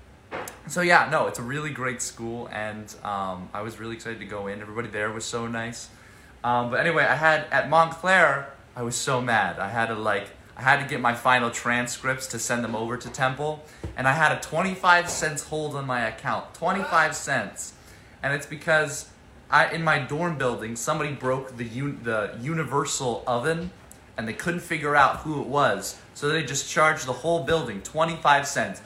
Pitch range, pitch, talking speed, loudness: 115-155 Hz, 130 Hz, 210 wpm, -25 LUFS